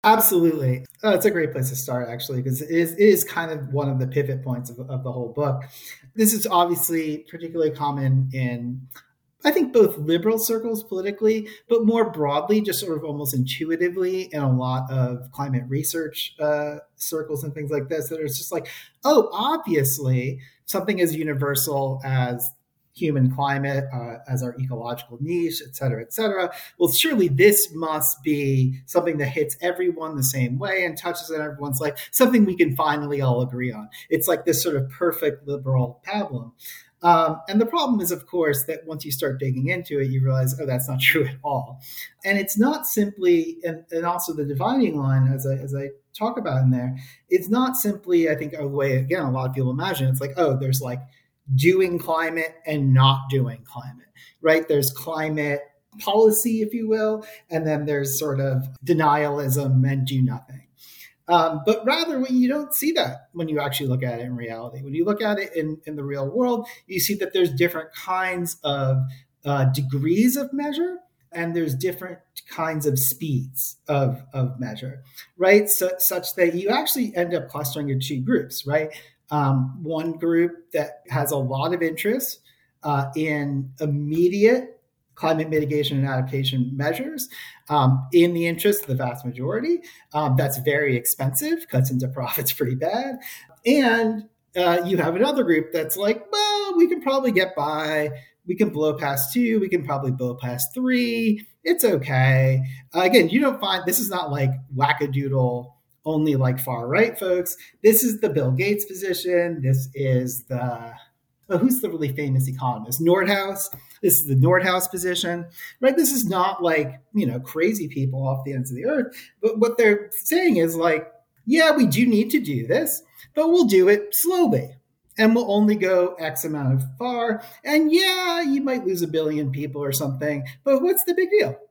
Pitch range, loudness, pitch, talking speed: 135-190 Hz, -22 LUFS, 155 Hz, 185 wpm